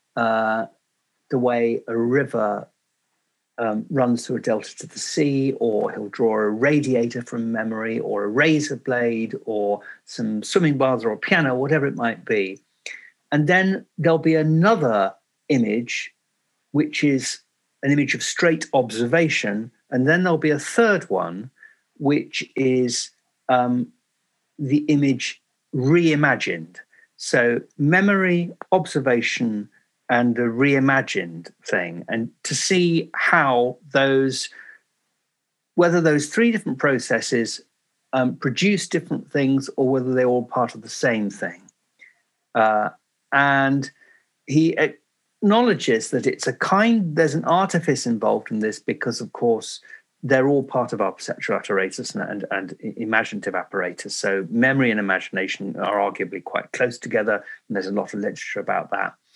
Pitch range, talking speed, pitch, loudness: 120-165 Hz, 140 wpm, 135 Hz, -21 LUFS